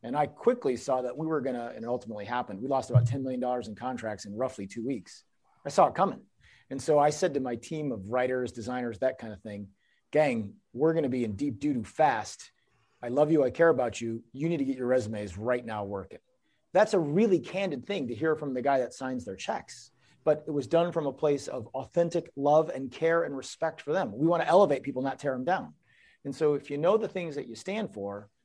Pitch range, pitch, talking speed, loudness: 120-155 Hz, 135 Hz, 245 wpm, -29 LUFS